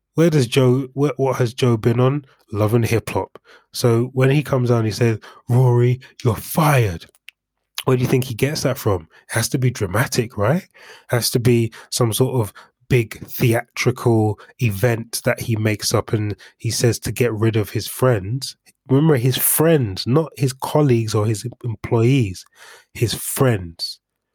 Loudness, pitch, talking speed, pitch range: -19 LUFS, 120 Hz, 175 wpm, 115-130 Hz